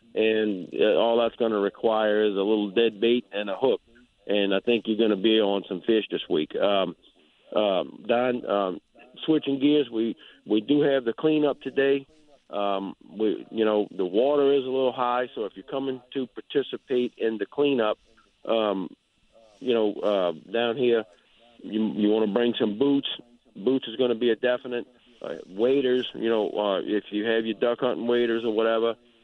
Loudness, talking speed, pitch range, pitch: -25 LUFS, 190 wpm, 110-125 Hz, 115 Hz